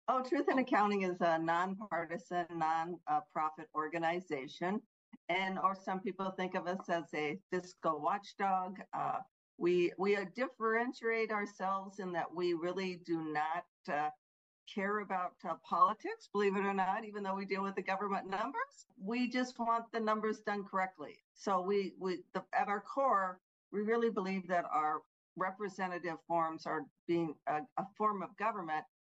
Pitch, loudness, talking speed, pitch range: 190 Hz, -37 LUFS, 155 wpm, 170-210 Hz